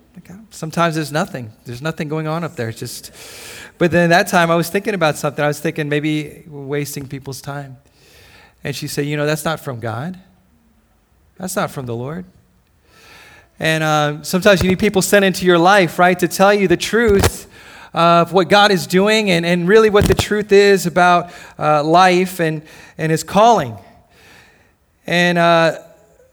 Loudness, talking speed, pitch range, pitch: -15 LUFS, 180 wpm, 150-190 Hz, 170 Hz